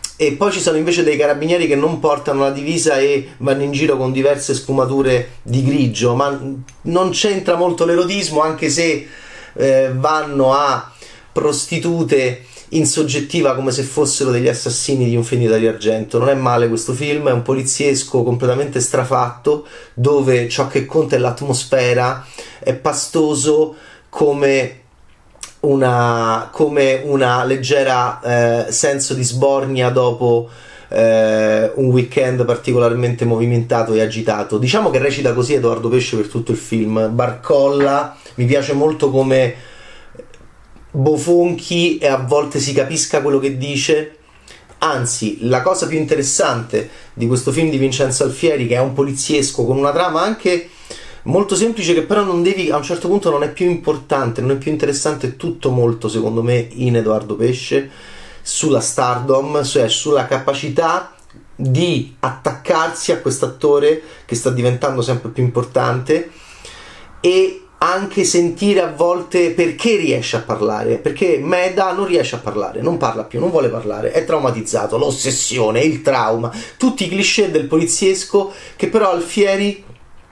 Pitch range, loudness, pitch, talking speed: 125-160 Hz, -16 LUFS, 140 Hz, 145 wpm